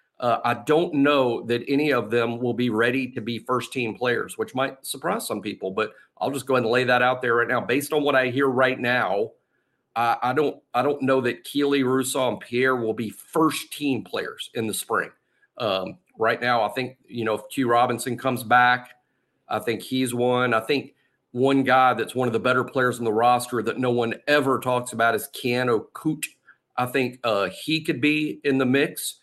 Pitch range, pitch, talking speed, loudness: 120-135 Hz, 125 Hz, 220 wpm, -23 LUFS